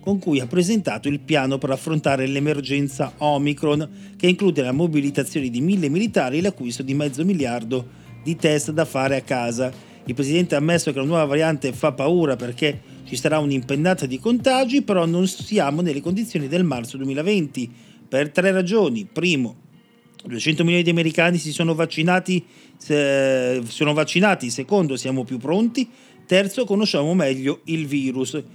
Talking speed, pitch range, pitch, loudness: 160 wpm, 135-180 Hz, 150 Hz, -21 LUFS